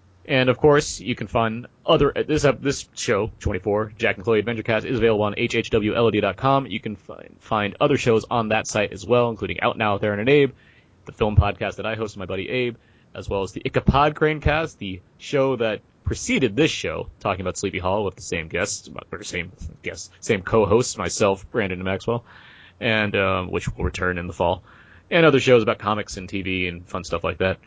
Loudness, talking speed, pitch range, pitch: -22 LUFS, 215 wpm, 95-125 Hz, 110 Hz